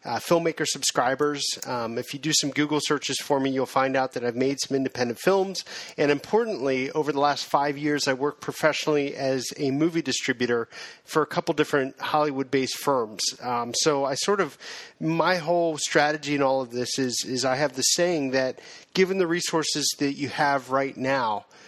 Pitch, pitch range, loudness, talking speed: 140 Hz, 135-155 Hz, -25 LUFS, 195 wpm